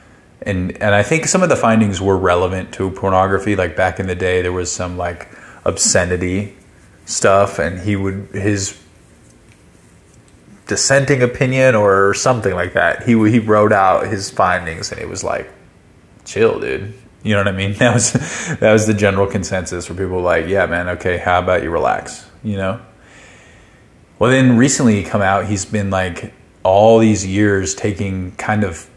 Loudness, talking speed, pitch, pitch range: -15 LUFS, 175 wpm, 100 Hz, 90-110 Hz